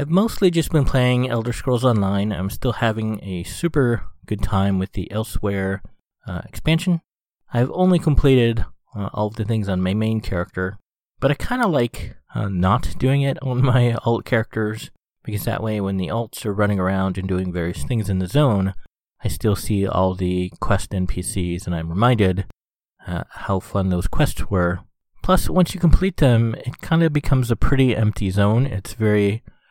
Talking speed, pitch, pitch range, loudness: 185 wpm, 110 Hz, 95-125 Hz, -21 LUFS